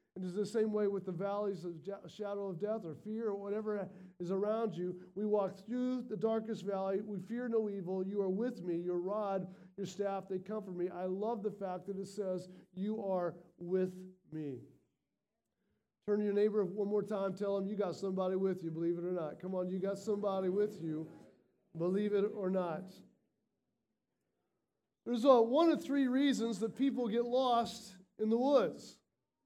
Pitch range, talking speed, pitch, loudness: 185-215 Hz, 190 wpm, 200 Hz, -36 LUFS